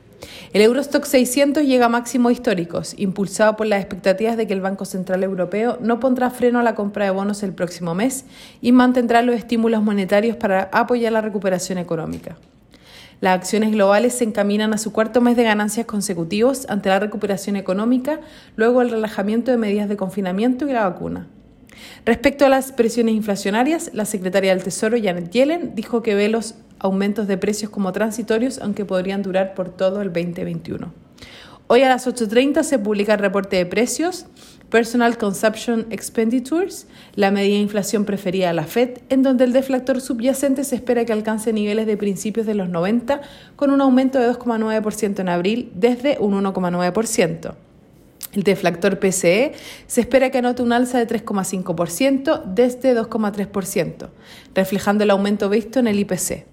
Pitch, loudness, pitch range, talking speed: 220 Hz, -19 LUFS, 200-245 Hz, 165 wpm